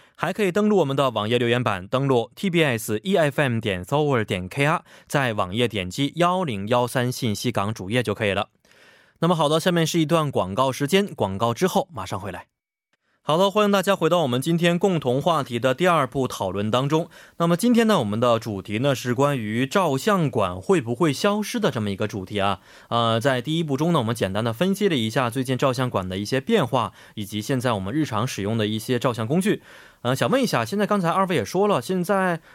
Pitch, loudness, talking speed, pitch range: 130 Hz, -22 LUFS, 335 characters per minute, 110-170 Hz